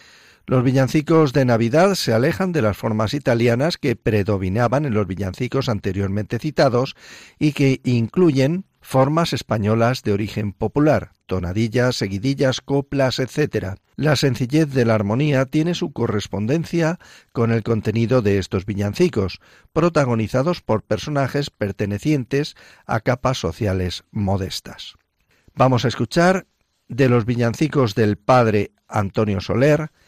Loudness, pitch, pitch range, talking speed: -20 LUFS, 120 Hz, 105-140 Hz, 120 wpm